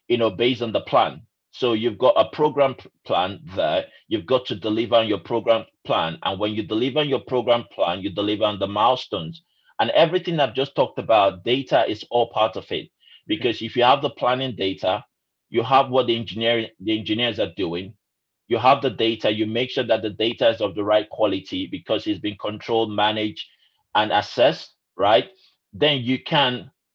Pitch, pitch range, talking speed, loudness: 115 Hz, 105-130 Hz, 195 wpm, -22 LUFS